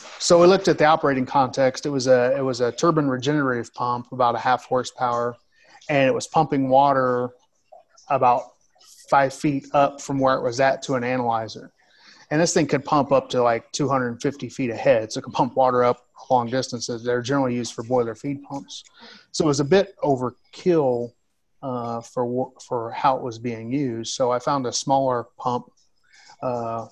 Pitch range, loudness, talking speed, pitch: 120-140 Hz, -22 LUFS, 185 wpm, 130 Hz